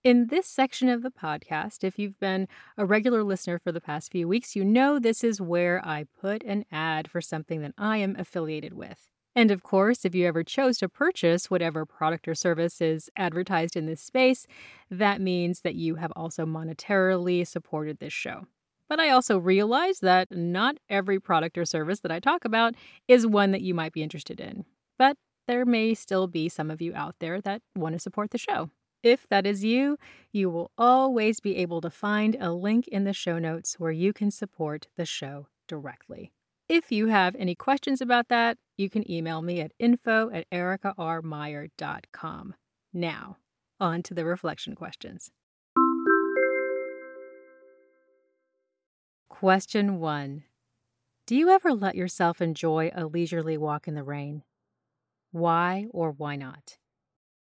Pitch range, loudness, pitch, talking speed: 160-210 Hz, -26 LUFS, 180 Hz, 170 wpm